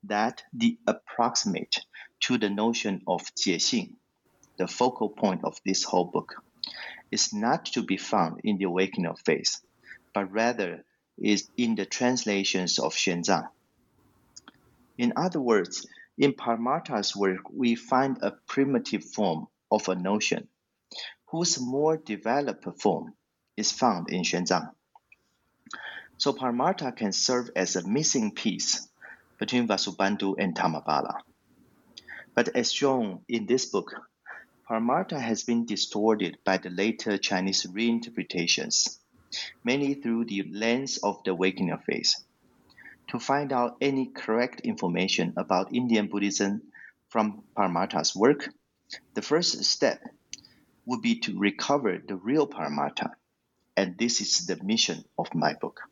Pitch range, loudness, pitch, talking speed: 100-130 Hz, -27 LUFS, 115 Hz, 130 wpm